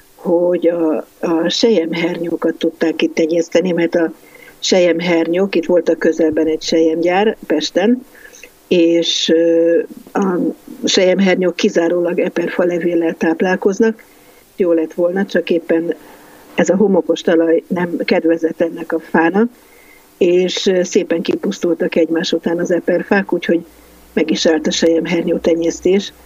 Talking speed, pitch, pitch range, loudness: 120 wpm, 170 Hz, 165-180 Hz, -15 LUFS